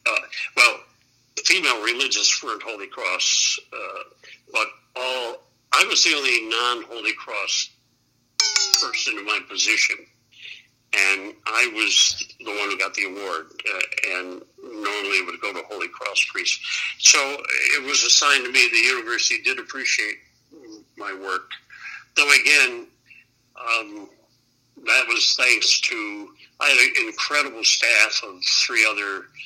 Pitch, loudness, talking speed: 325 Hz, -19 LUFS, 135 wpm